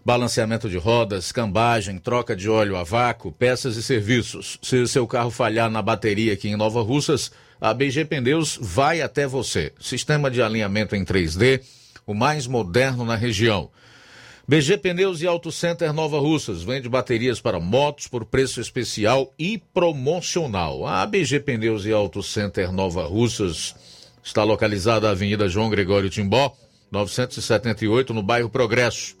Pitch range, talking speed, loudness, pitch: 110-135 Hz, 150 wpm, -22 LUFS, 120 Hz